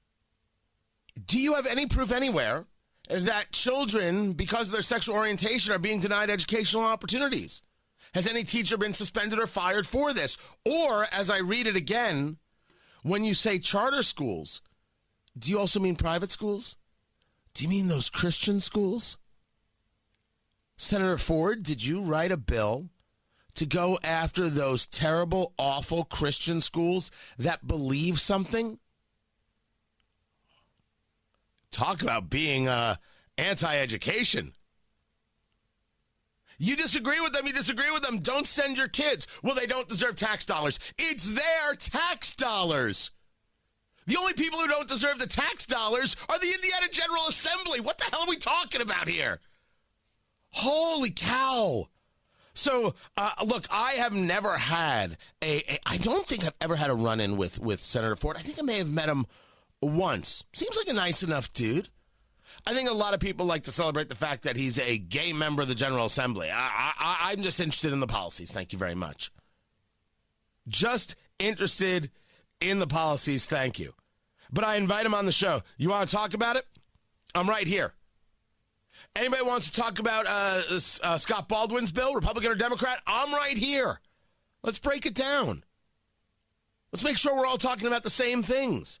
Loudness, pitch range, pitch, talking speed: -27 LUFS, 145-245 Hz, 195 Hz, 160 wpm